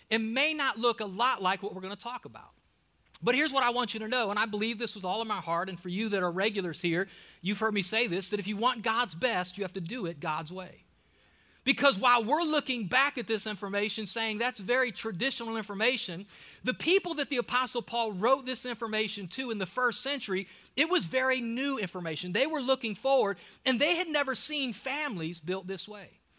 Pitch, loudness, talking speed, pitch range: 225 Hz, -30 LUFS, 225 wpm, 195-255 Hz